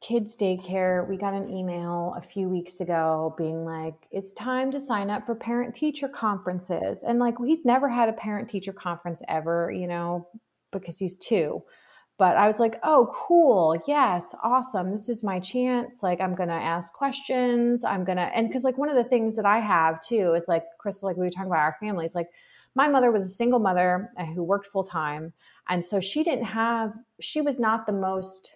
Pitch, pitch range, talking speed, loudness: 195 Hz, 175-235 Hz, 210 wpm, -26 LUFS